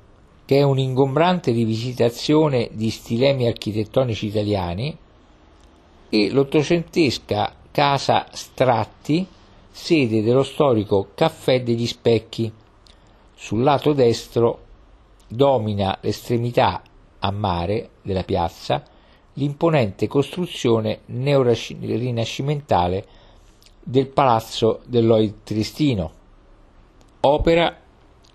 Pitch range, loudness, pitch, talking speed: 105-135 Hz, -20 LUFS, 115 Hz, 70 wpm